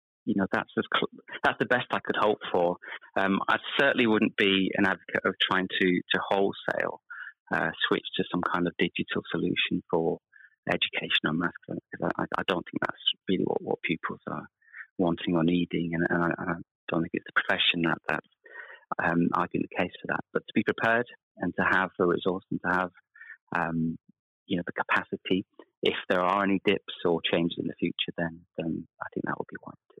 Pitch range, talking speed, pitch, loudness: 85-100 Hz, 205 wpm, 85 Hz, -28 LUFS